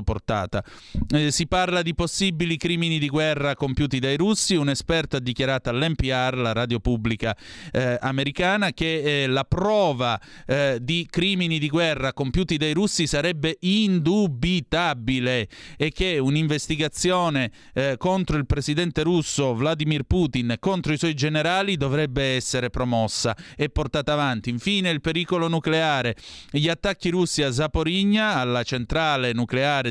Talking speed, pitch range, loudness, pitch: 135 wpm, 130-170 Hz, -23 LUFS, 150 Hz